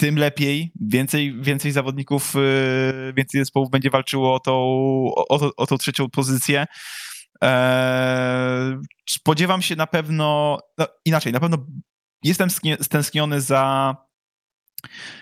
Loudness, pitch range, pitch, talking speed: -20 LUFS, 130-150 Hz, 140 Hz, 115 wpm